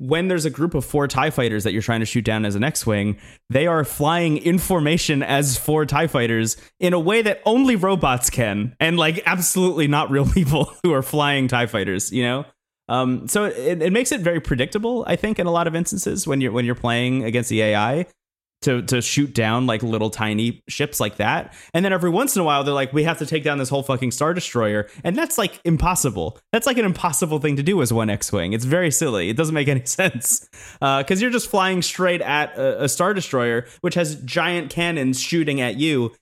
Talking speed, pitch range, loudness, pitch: 230 wpm, 125-175 Hz, -20 LUFS, 145 Hz